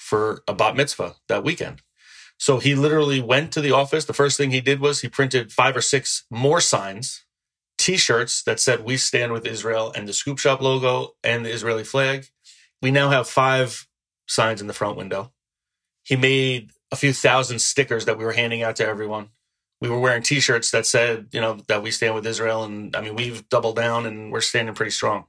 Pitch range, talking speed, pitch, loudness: 110-135 Hz, 215 wpm, 125 Hz, -21 LUFS